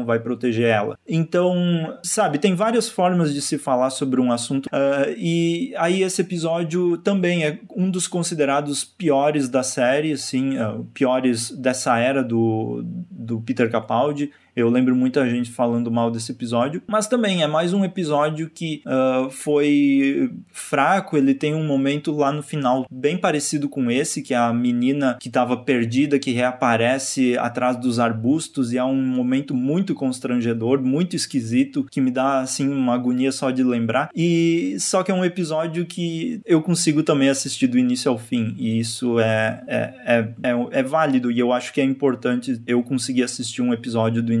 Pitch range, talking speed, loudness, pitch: 125-165 Hz, 175 wpm, -21 LUFS, 135 Hz